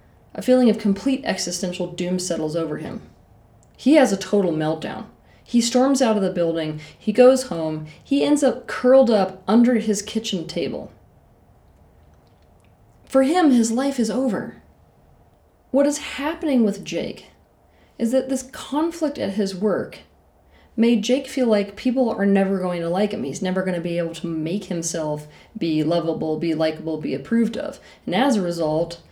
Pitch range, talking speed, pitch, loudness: 170-255 Hz, 165 wpm, 200 Hz, -21 LUFS